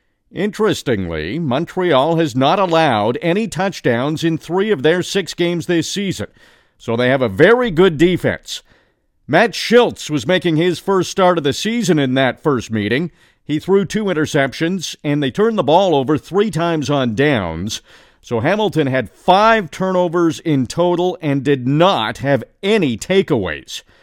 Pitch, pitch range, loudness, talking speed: 165 Hz, 145-190 Hz, -16 LUFS, 155 wpm